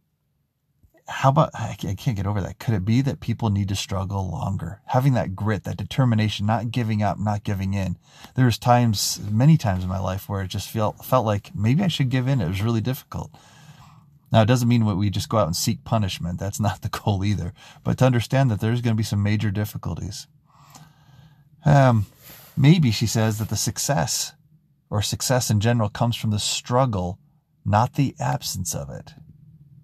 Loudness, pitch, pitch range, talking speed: -23 LUFS, 115 Hz, 100-140 Hz, 195 wpm